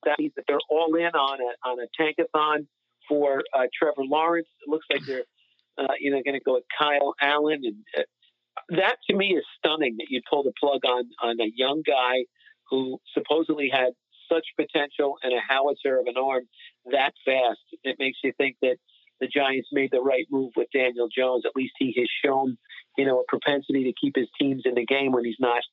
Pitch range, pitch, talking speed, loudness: 130-155 Hz, 140 Hz, 210 wpm, -25 LUFS